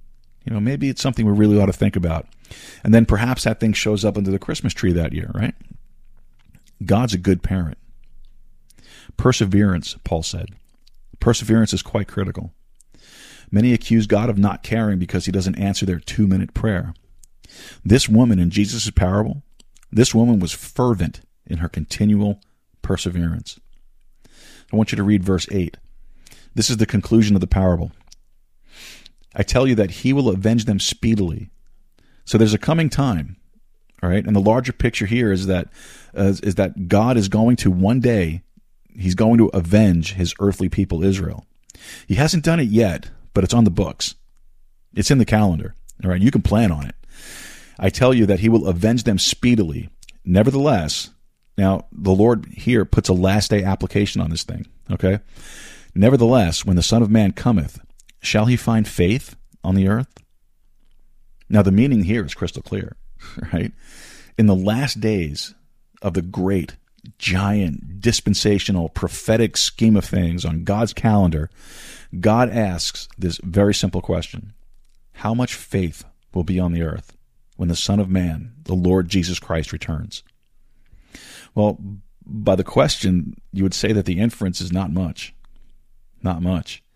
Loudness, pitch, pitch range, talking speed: -19 LUFS, 100 Hz, 90-115 Hz, 165 wpm